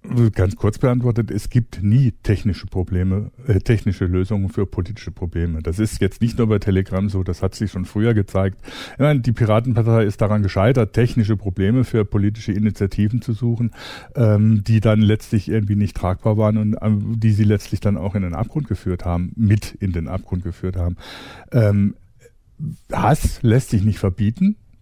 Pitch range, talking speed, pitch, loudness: 95-115 Hz, 175 wpm, 105 Hz, -19 LUFS